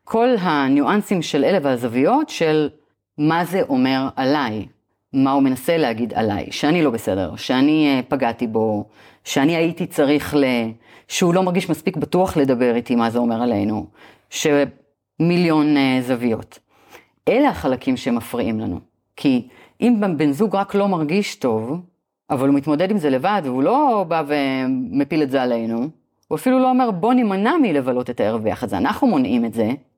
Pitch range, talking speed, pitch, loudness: 130-190 Hz, 155 wpm, 150 Hz, -19 LUFS